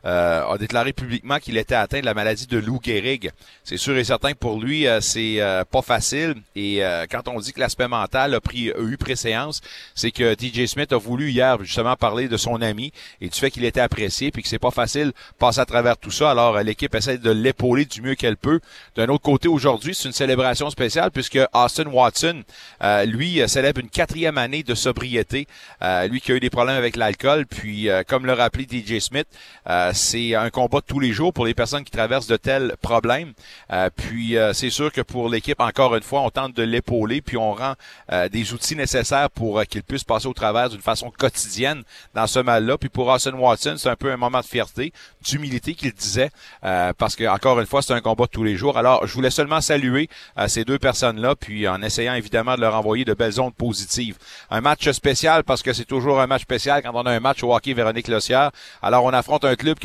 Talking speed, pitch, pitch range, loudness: 235 wpm, 125 Hz, 115-135 Hz, -21 LUFS